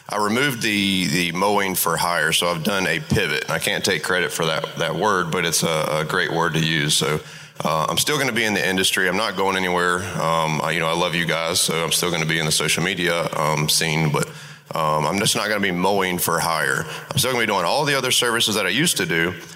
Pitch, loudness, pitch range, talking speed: 90 Hz, -20 LUFS, 80-95 Hz, 270 wpm